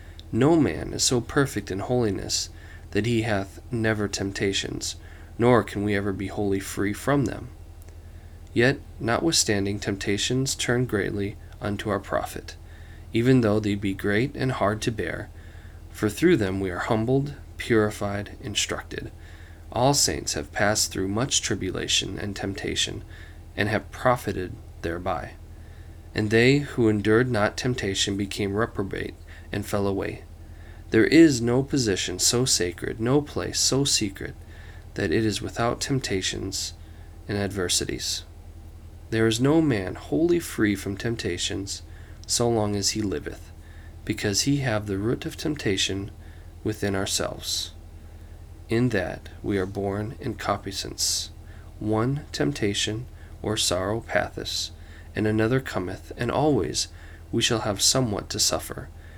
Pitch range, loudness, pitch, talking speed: 85-110 Hz, -25 LUFS, 100 Hz, 135 wpm